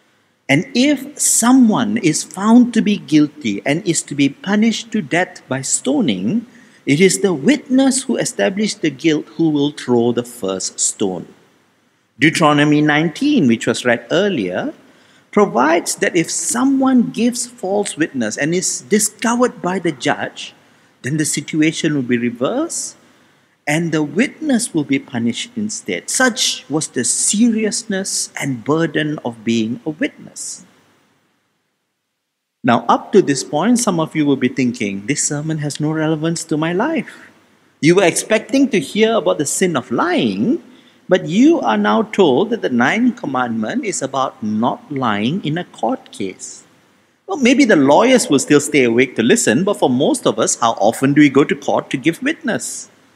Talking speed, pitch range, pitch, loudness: 165 wpm, 145-235 Hz, 185 Hz, -16 LUFS